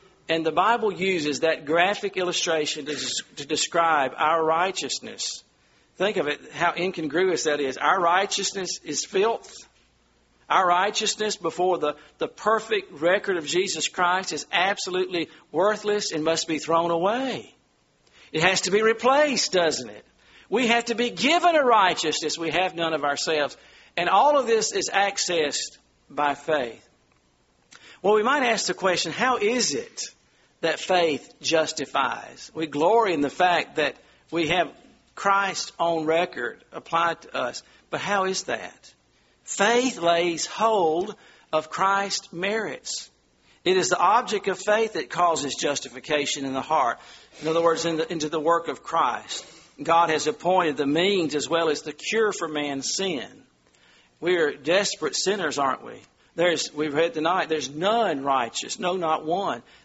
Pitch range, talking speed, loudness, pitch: 150-200 Hz, 155 wpm, -24 LUFS, 170 Hz